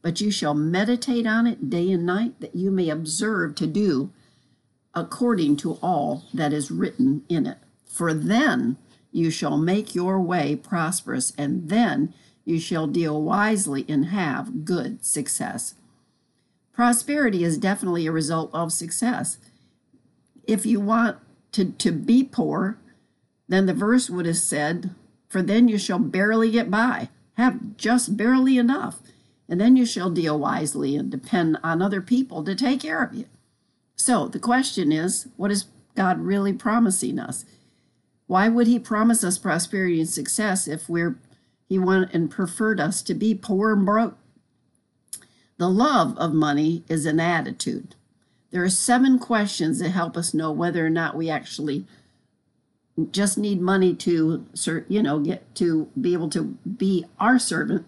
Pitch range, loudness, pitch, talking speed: 165-230 Hz, -23 LUFS, 190 Hz, 160 wpm